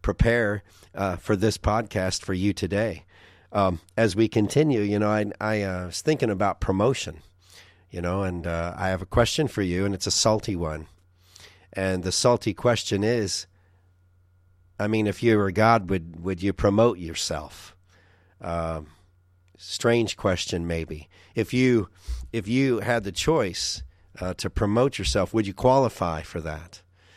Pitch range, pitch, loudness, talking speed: 90-110 Hz, 95 Hz, -25 LUFS, 160 wpm